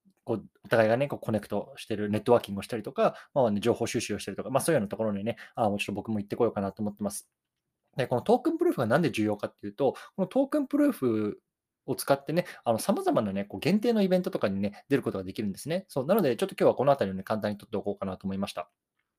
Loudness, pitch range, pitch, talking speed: -29 LUFS, 100-160 Hz, 110 Hz, 565 characters per minute